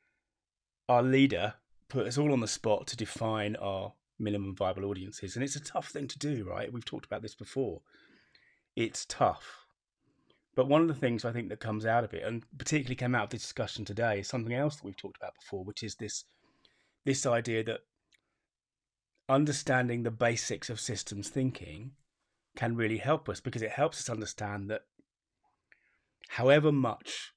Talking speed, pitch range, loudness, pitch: 180 wpm, 105-135 Hz, -32 LUFS, 120 Hz